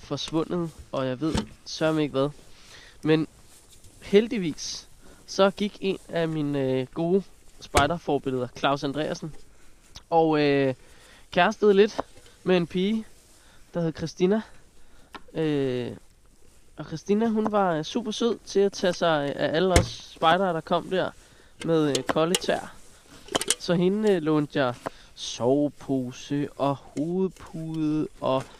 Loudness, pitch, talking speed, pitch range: -26 LUFS, 160 Hz, 130 wpm, 140-185 Hz